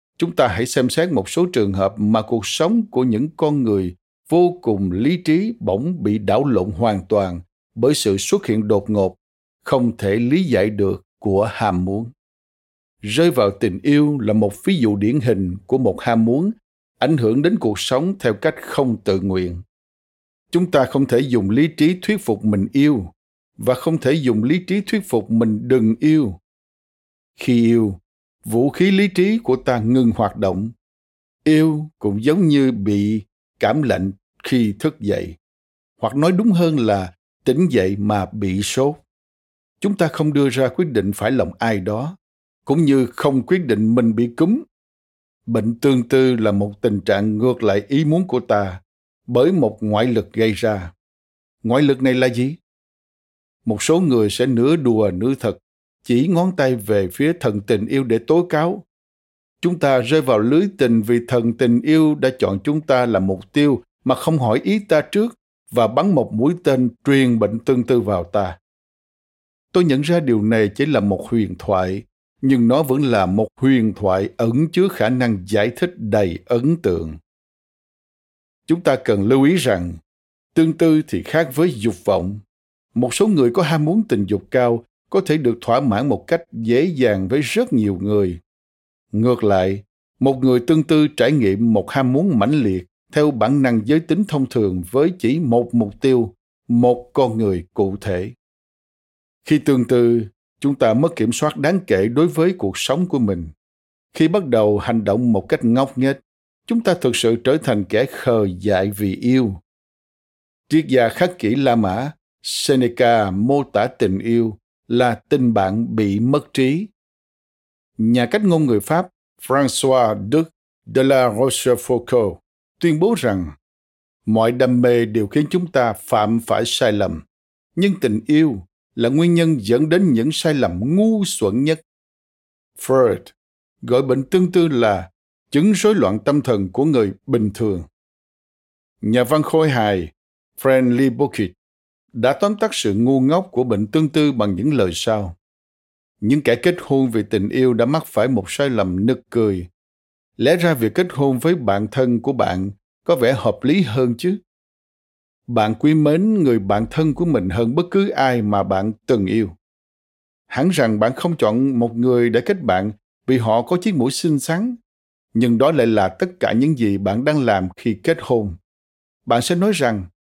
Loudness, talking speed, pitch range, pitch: -18 LUFS, 180 wpm, 100-150 Hz, 120 Hz